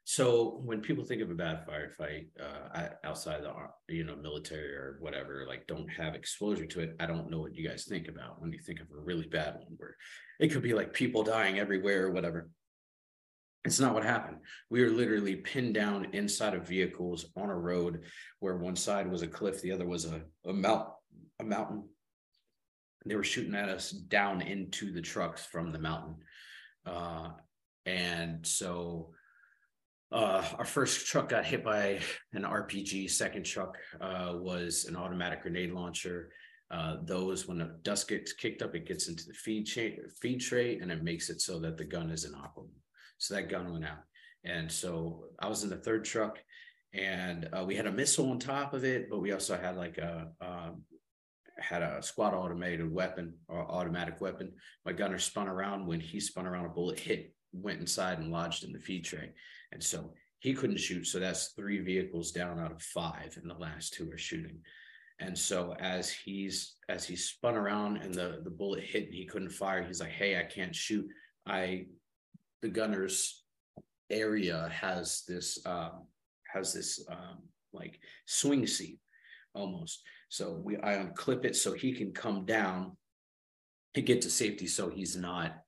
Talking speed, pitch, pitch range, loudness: 190 wpm, 90 Hz, 85-100 Hz, -35 LUFS